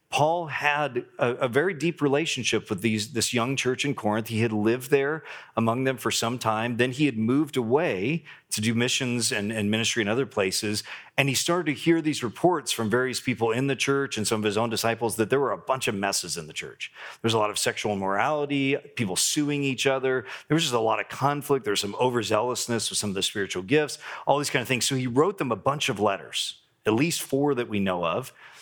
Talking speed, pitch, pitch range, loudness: 240 wpm, 125 Hz, 110-140 Hz, -25 LUFS